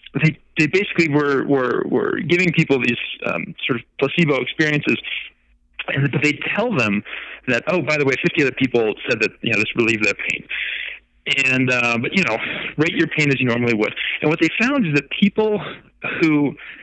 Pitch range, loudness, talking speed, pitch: 125-165 Hz, -19 LUFS, 200 wpm, 145 Hz